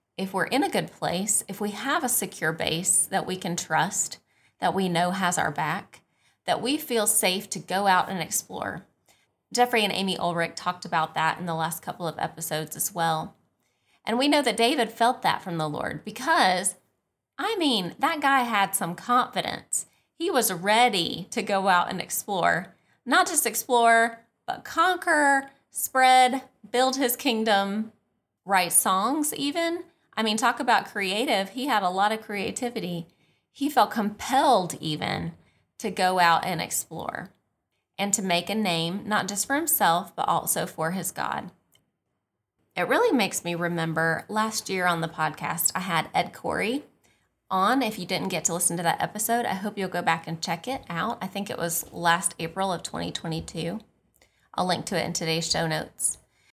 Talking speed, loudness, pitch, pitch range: 175 wpm, -25 LUFS, 195 Hz, 170-235 Hz